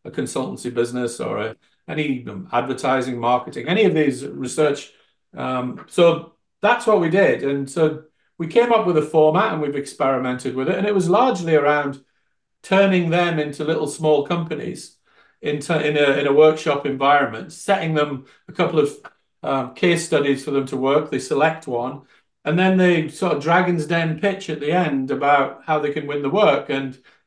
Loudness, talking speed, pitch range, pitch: -20 LUFS, 185 wpm, 135-165 Hz, 150 Hz